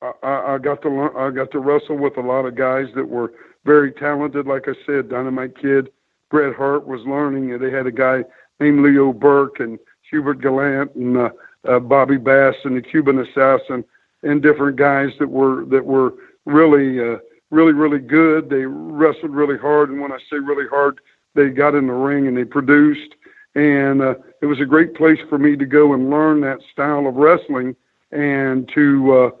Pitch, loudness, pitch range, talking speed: 140 Hz, -16 LUFS, 130-145 Hz, 200 wpm